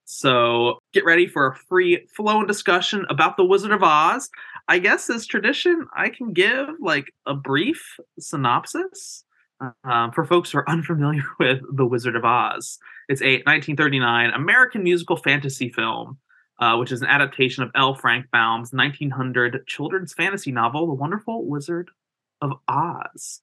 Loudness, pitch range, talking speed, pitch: -20 LUFS, 130-190 Hz, 155 wpm, 150 Hz